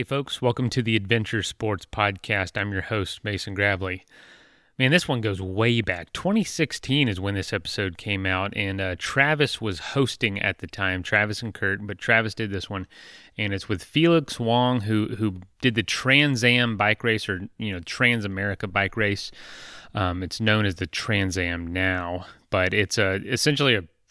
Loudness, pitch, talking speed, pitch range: -24 LUFS, 105 Hz, 185 wpm, 95-120 Hz